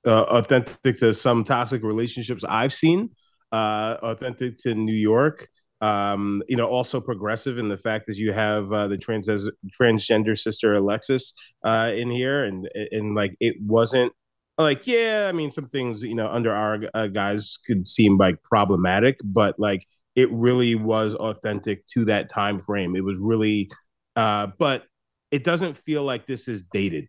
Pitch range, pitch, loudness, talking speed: 105-125 Hz, 110 Hz, -23 LUFS, 170 wpm